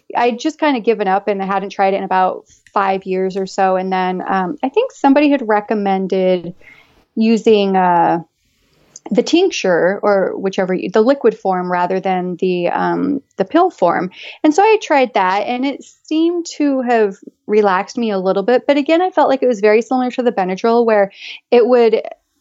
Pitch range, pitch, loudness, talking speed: 190-270 Hz, 215 Hz, -15 LUFS, 190 wpm